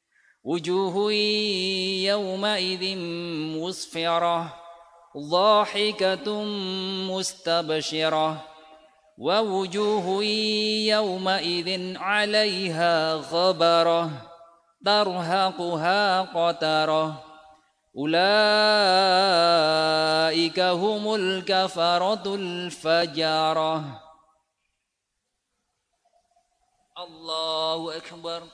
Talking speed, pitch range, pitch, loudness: 35 wpm, 160-195 Hz, 175 Hz, -23 LUFS